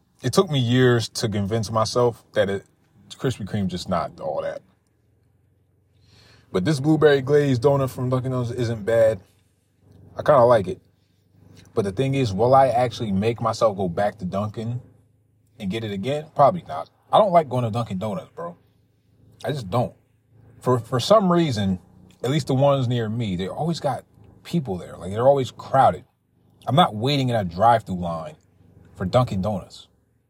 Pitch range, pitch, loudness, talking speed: 100-135 Hz, 115 Hz, -22 LUFS, 180 wpm